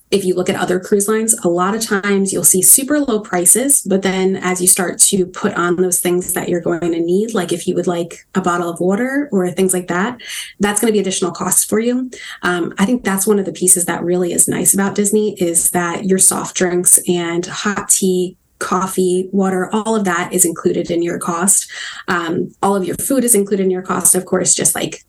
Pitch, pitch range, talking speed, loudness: 185 Hz, 180-200 Hz, 235 wpm, -14 LUFS